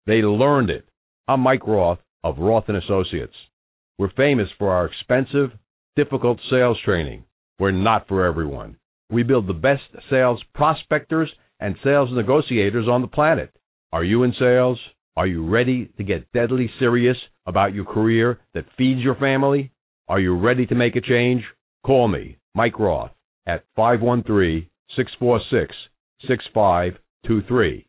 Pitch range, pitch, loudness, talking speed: 100-130 Hz, 120 Hz, -20 LUFS, 145 wpm